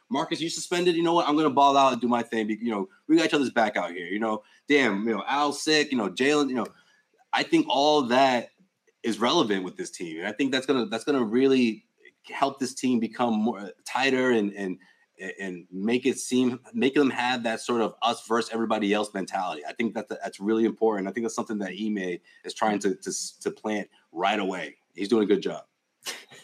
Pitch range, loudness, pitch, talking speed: 110-145 Hz, -26 LUFS, 120 Hz, 225 wpm